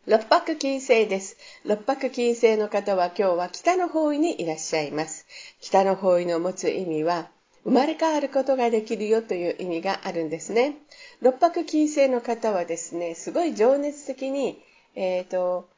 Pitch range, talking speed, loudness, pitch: 180-275 Hz, 325 characters per minute, -24 LUFS, 225 Hz